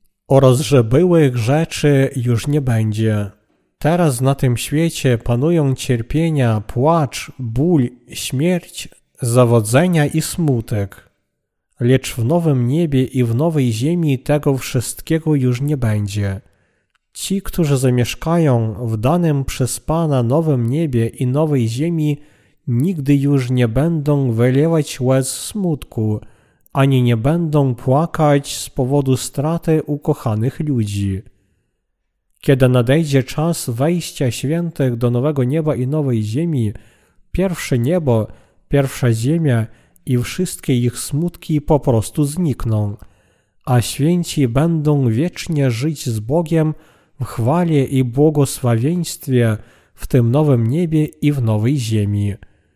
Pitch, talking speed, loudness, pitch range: 135 Hz, 115 wpm, -17 LUFS, 120-155 Hz